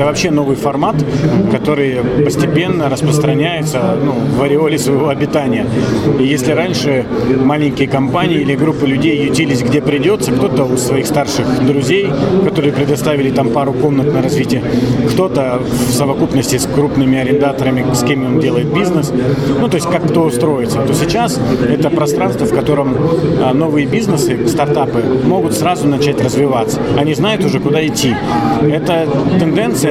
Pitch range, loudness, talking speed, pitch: 135-150 Hz, -13 LUFS, 145 wpm, 140 Hz